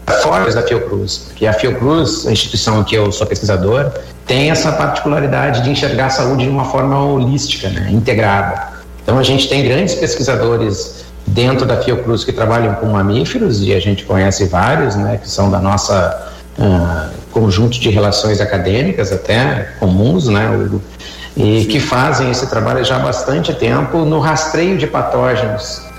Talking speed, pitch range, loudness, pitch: 160 wpm, 100-130 Hz, -14 LUFS, 110 Hz